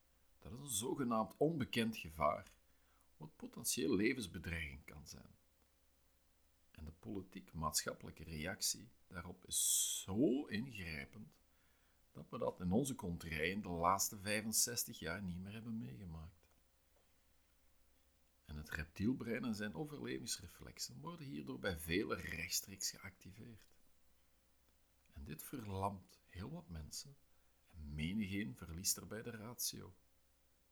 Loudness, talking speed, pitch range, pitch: -41 LUFS, 110 wpm, 65-105 Hz, 85 Hz